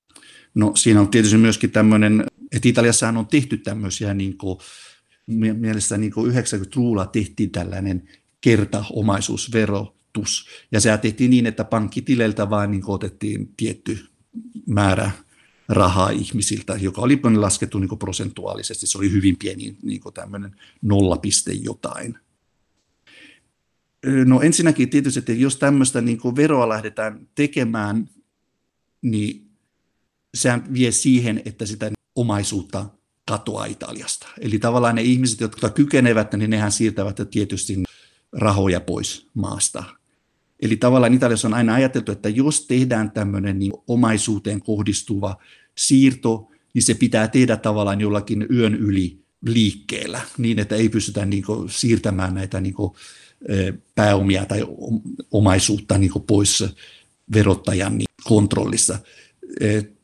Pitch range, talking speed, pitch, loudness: 100-120 Hz, 120 wpm, 110 Hz, -20 LUFS